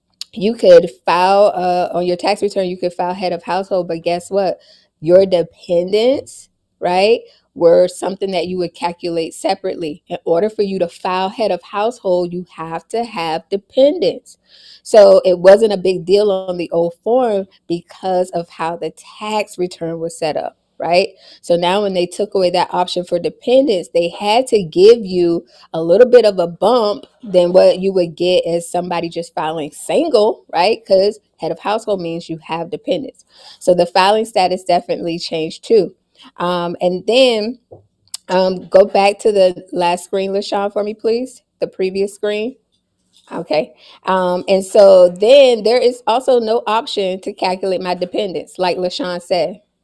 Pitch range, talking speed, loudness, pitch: 175-210 Hz, 170 wpm, -15 LUFS, 185 Hz